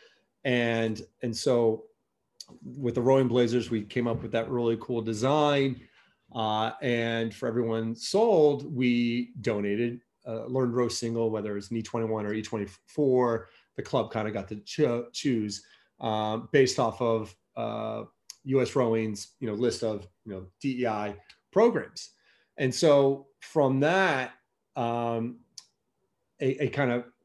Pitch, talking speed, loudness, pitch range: 120 Hz, 145 wpm, -28 LUFS, 110-130 Hz